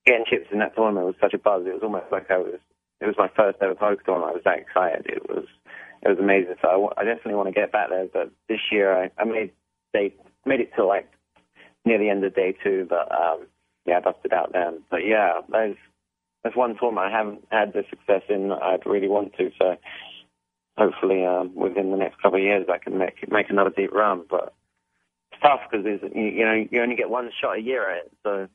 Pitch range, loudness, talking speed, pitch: 90-110 Hz, -23 LUFS, 240 wpm, 100 Hz